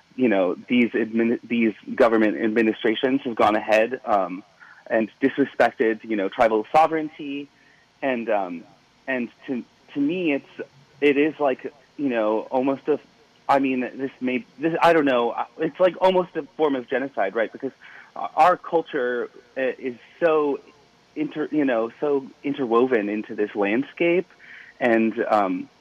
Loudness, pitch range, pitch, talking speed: -23 LUFS, 115-160 Hz, 135 Hz, 145 wpm